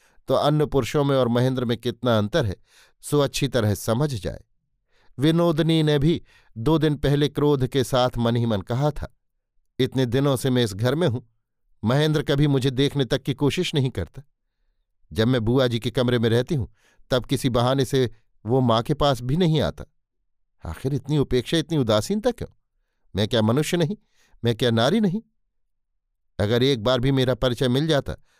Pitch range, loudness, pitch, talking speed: 115-145 Hz, -22 LUFS, 130 Hz, 185 wpm